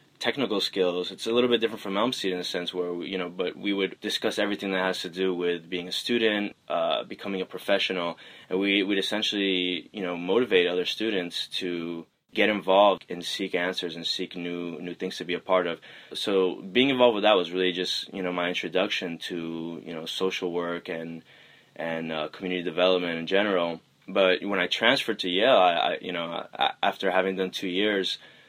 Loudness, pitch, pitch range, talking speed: -26 LUFS, 90 Hz, 90-95 Hz, 205 wpm